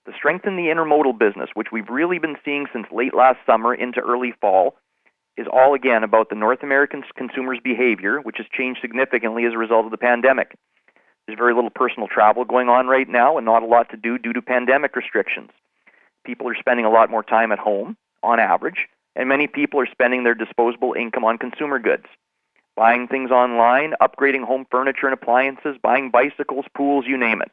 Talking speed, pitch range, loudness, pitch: 200 wpm, 115-135 Hz, -19 LUFS, 125 Hz